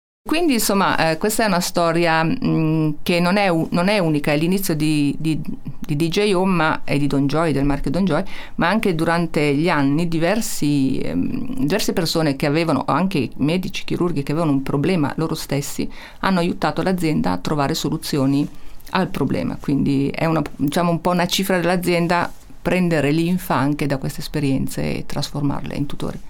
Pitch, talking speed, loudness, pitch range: 165 Hz, 180 wpm, -20 LUFS, 145-180 Hz